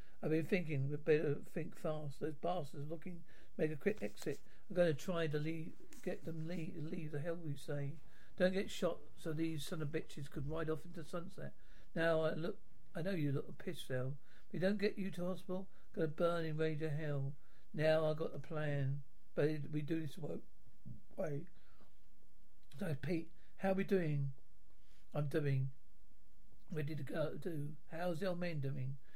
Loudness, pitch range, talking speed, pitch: -41 LUFS, 150-175 Hz, 190 wpm, 160 Hz